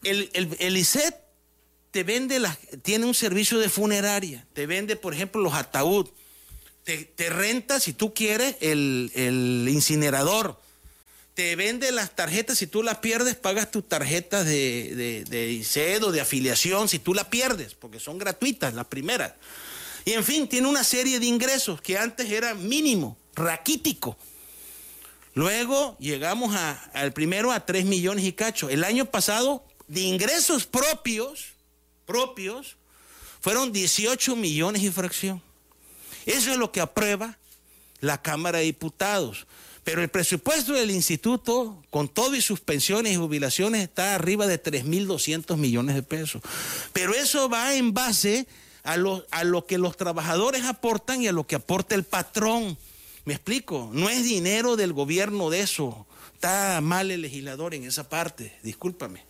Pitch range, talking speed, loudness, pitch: 150-225 Hz, 155 wpm, -25 LUFS, 190 Hz